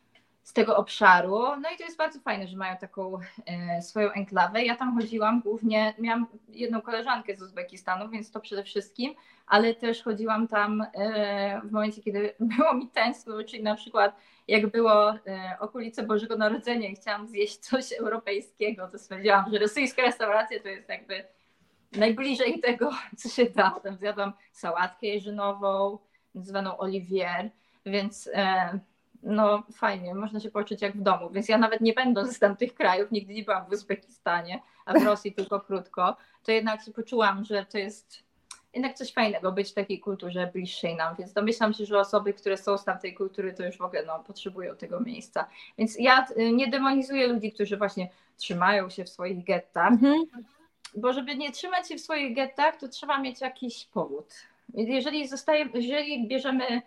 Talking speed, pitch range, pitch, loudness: 170 wpm, 200-240 Hz, 215 Hz, -27 LUFS